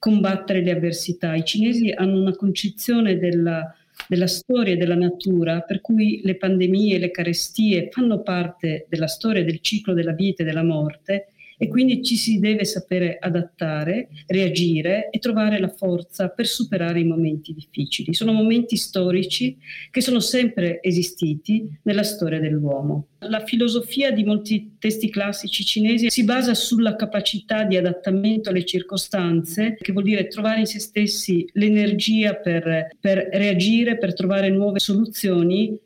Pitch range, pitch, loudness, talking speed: 175-215 Hz, 195 Hz, -21 LUFS, 150 wpm